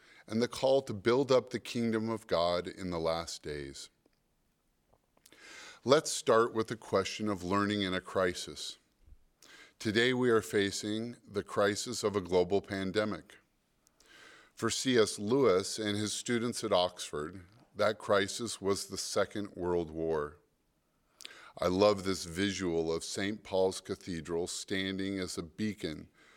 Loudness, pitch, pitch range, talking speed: -32 LUFS, 100 Hz, 90-110 Hz, 140 wpm